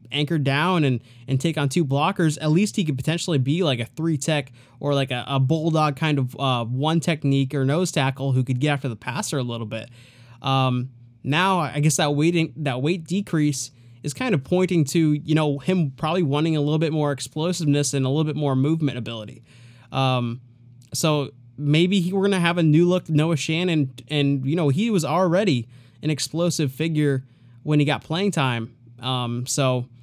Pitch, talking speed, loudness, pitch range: 145 Hz, 200 wpm, -22 LUFS, 130-160 Hz